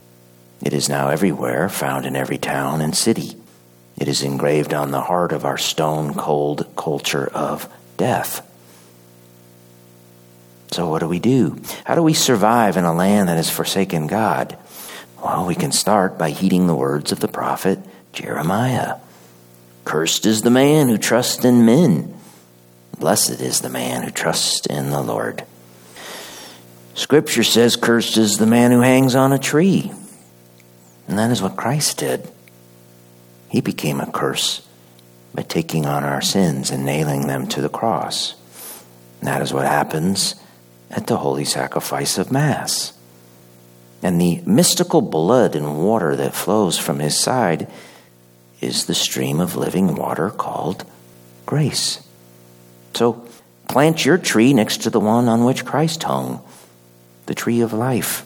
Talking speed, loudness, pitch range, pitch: 150 wpm, -18 LUFS, 60-95 Hz, 65 Hz